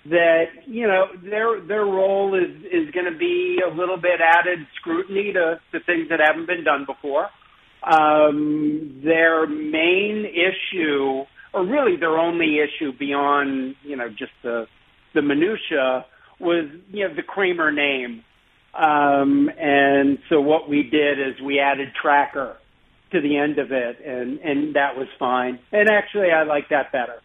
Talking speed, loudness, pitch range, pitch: 160 wpm, -20 LUFS, 140-180 Hz, 155 Hz